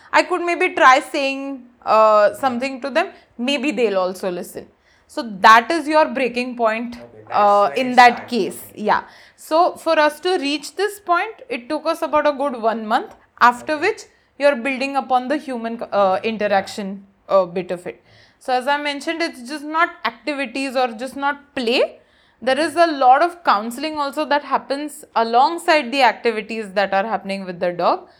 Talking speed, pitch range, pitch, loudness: 175 wpm, 225-310 Hz, 270 Hz, -18 LUFS